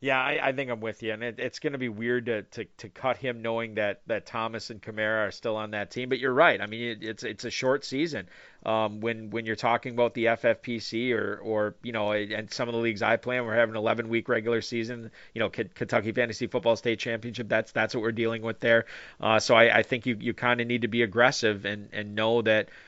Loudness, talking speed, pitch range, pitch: -27 LUFS, 260 wpm, 110-120 Hz, 115 Hz